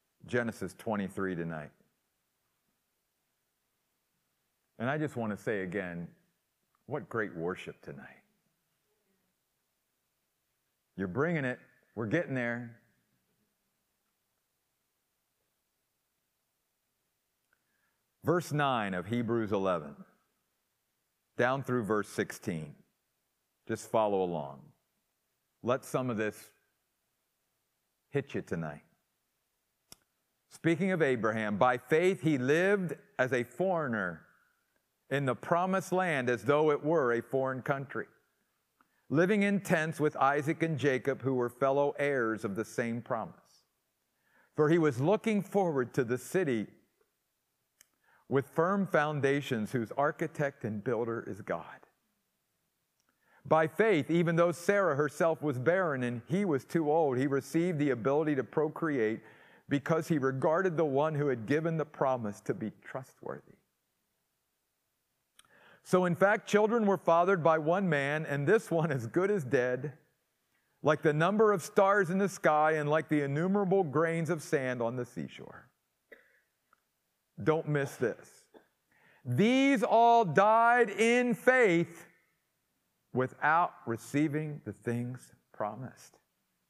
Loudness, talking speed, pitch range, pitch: -31 LUFS, 120 wpm, 125-170 Hz, 145 Hz